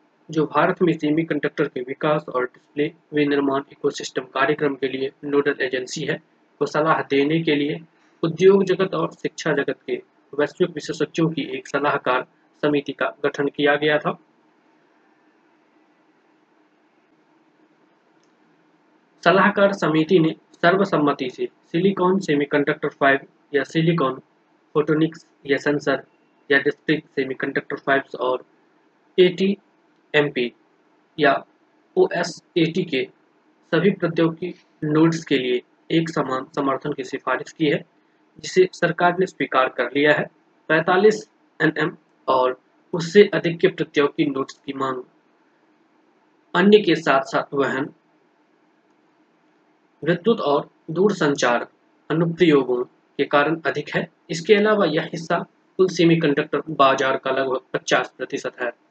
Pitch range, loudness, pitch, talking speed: 145-200 Hz, -21 LUFS, 160 Hz, 120 wpm